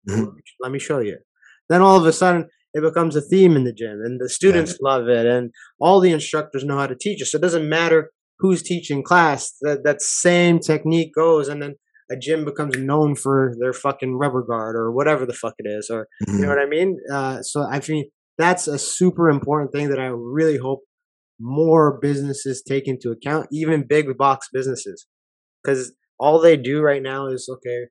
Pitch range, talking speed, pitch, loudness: 130-160 Hz, 205 wpm, 145 Hz, -19 LUFS